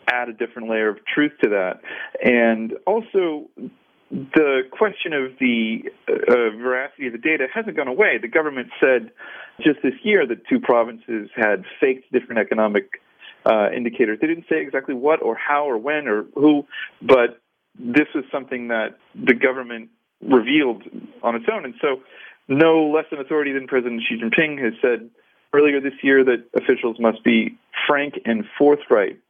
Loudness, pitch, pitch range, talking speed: -20 LUFS, 130 Hz, 115-150 Hz, 165 wpm